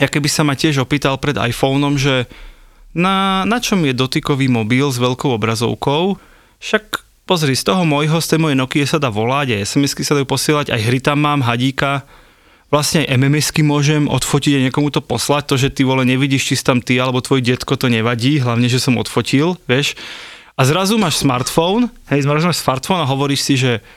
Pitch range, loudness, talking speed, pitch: 130-150 Hz, -15 LUFS, 195 wpm, 140 Hz